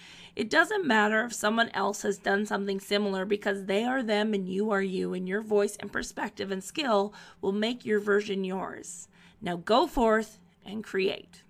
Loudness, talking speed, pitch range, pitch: -28 LUFS, 185 wpm, 195-220 Hz, 205 Hz